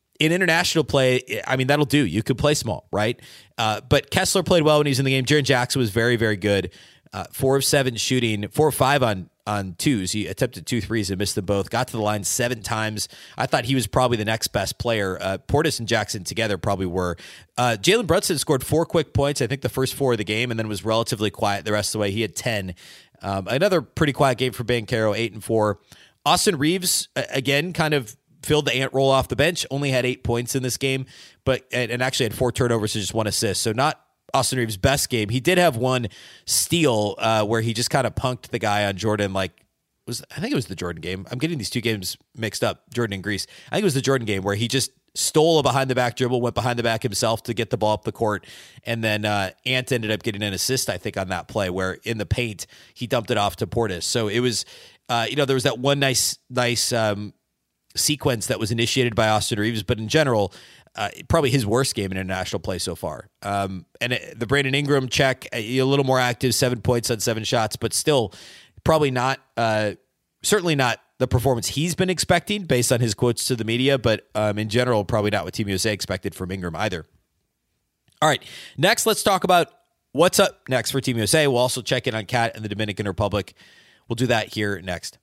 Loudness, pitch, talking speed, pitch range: -22 LUFS, 120 Hz, 240 wpm, 105-135 Hz